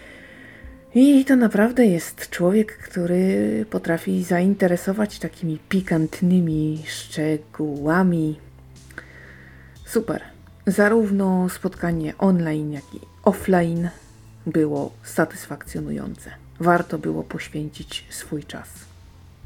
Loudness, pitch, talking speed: -22 LUFS, 165 Hz, 75 wpm